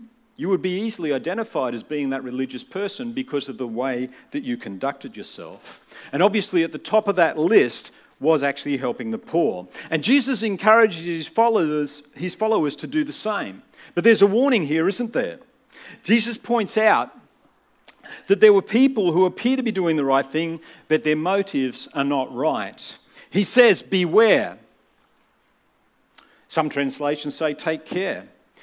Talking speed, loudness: 165 wpm, -21 LUFS